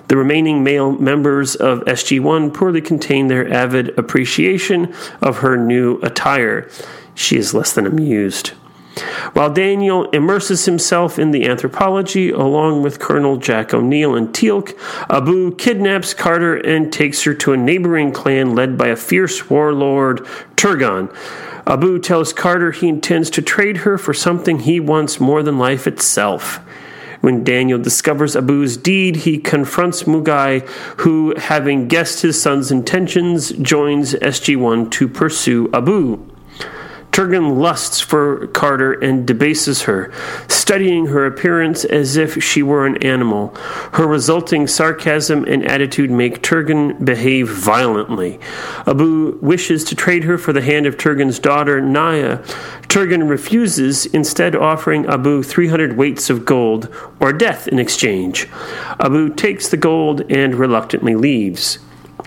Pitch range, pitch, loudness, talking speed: 135-170 Hz, 150 Hz, -14 LUFS, 140 wpm